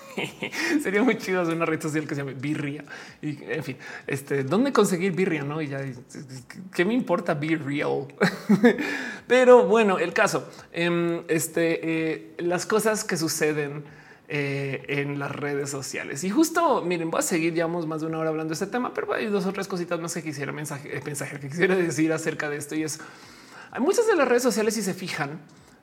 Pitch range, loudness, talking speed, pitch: 150-195 Hz, -25 LUFS, 195 wpm, 160 Hz